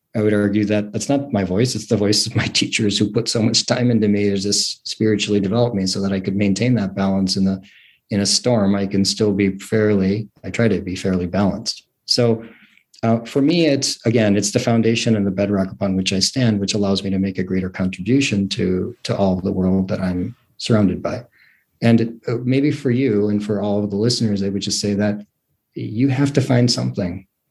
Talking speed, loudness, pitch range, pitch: 230 wpm, -19 LUFS, 100-115 Hz, 105 Hz